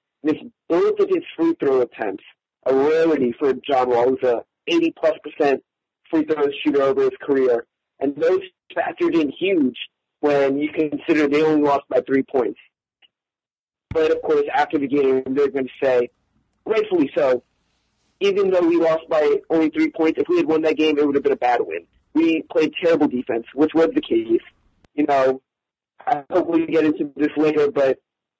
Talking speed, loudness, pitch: 185 wpm, -20 LUFS, 160 Hz